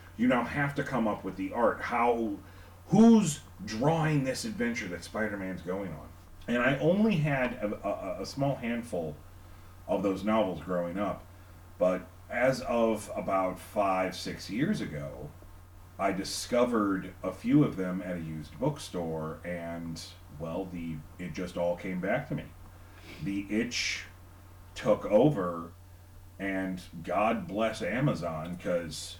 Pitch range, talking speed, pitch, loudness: 90-110 Hz, 140 wpm, 90 Hz, -30 LUFS